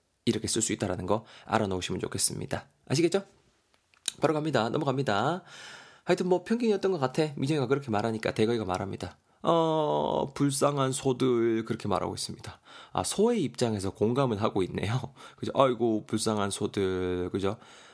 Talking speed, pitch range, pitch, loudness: 365 characters per minute, 100-140 Hz, 115 Hz, -29 LUFS